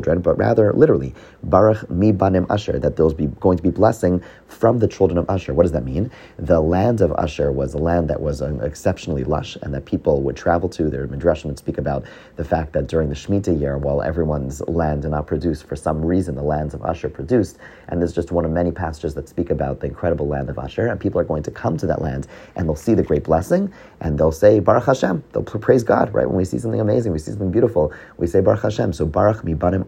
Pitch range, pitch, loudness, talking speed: 75-90 Hz, 80 Hz, -20 LUFS, 245 wpm